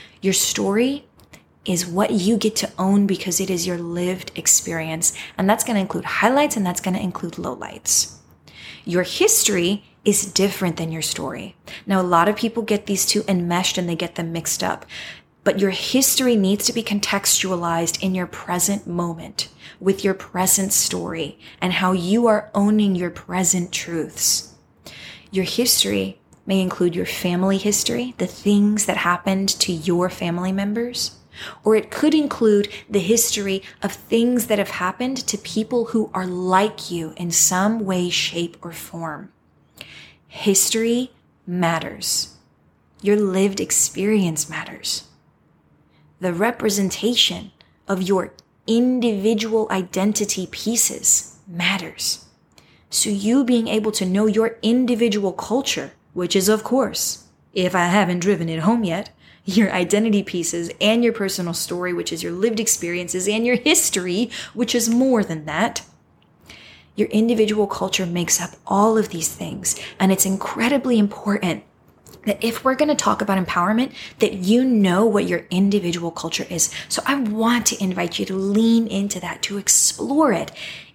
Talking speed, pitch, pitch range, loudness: 150 wpm, 200 Hz, 180-220 Hz, -20 LUFS